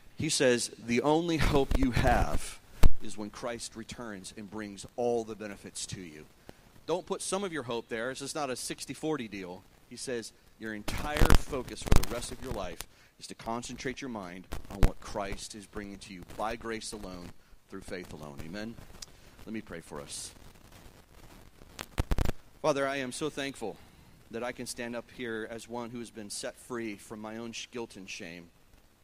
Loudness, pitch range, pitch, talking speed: -34 LUFS, 100-125 Hz, 110 Hz, 185 wpm